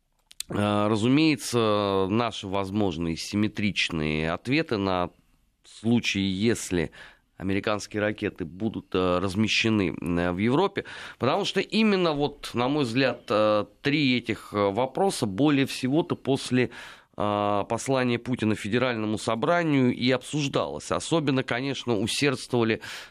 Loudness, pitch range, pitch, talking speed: -26 LUFS, 100-130 Hz, 110 Hz, 95 wpm